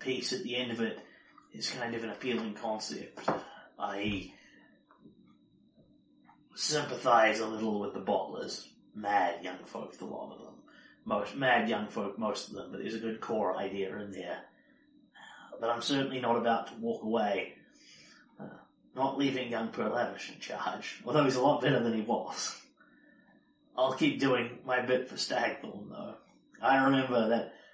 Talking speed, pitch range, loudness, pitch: 165 wpm, 110-125 Hz, -32 LUFS, 115 Hz